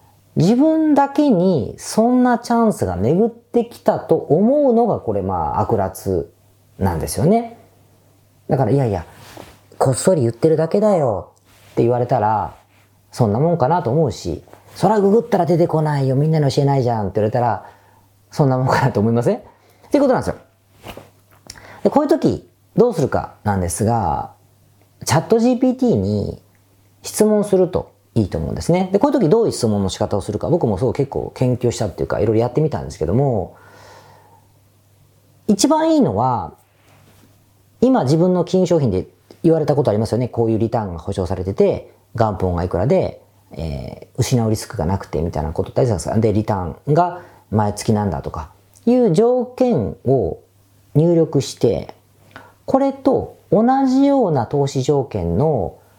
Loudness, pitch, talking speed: -18 LUFS, 120 Hz, 340 characters per minute